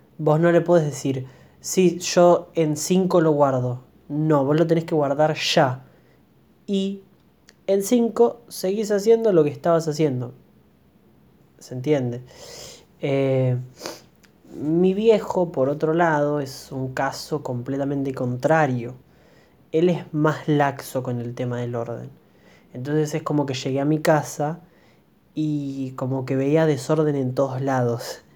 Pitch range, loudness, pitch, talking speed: 130-170 Hz, -22 LUFS, 150 Hz, 140 wpm